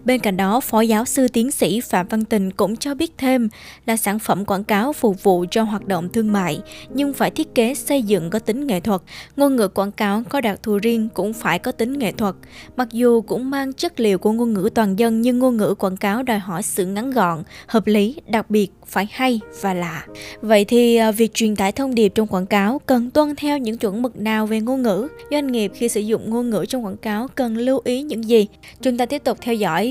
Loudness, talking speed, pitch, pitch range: -19 LUFS, 245 wpm, 225 Hz, 205-250 Hz